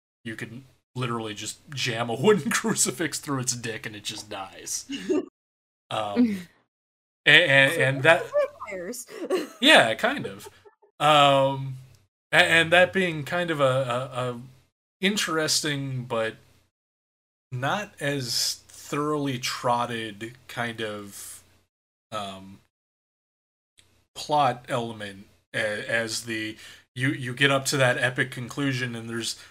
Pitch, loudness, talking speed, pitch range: 125 Hz, -24 LUFS, 115 wpm, 110-145 Hz